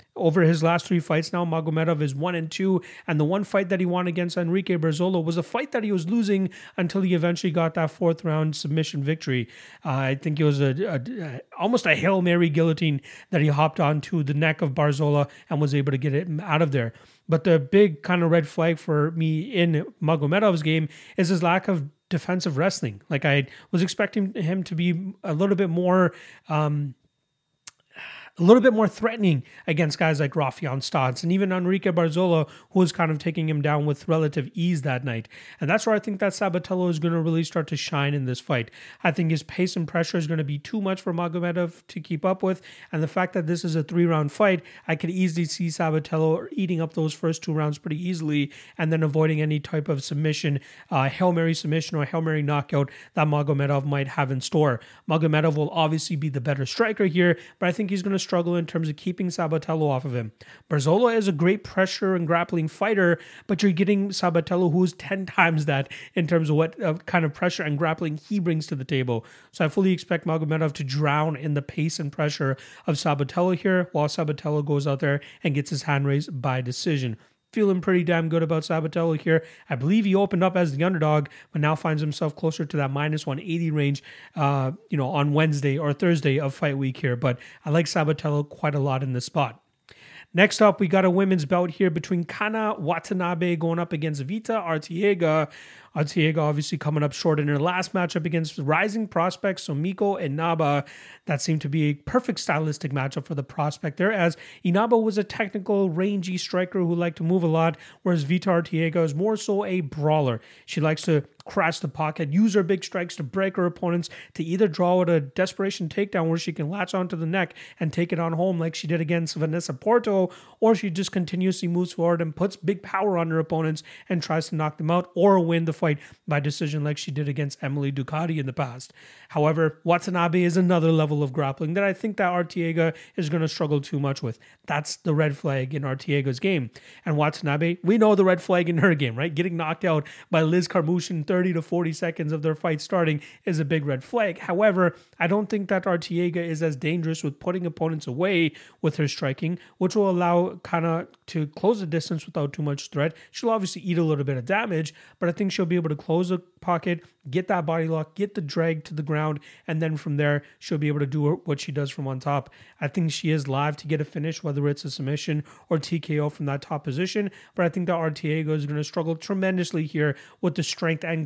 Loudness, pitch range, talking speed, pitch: -24 LUFS, 150-180 Hz, 220 wpm, 165 Hz